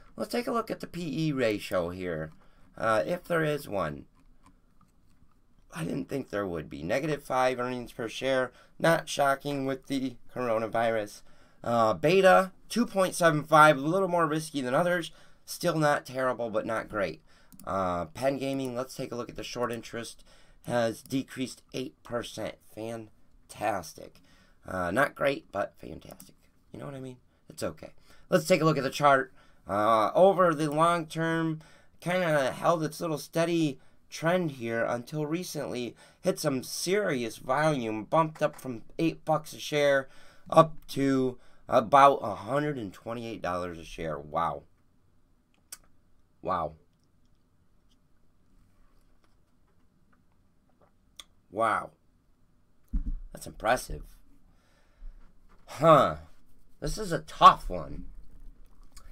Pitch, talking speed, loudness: 130 Hz, 125 wpm, -28 LUFS